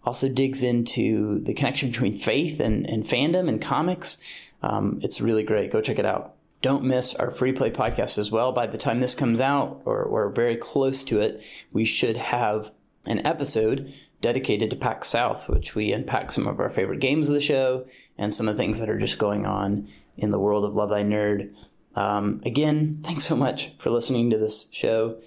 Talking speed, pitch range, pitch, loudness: 205 wpm, 105-135 Hz, 120 Hz, -24 LUFS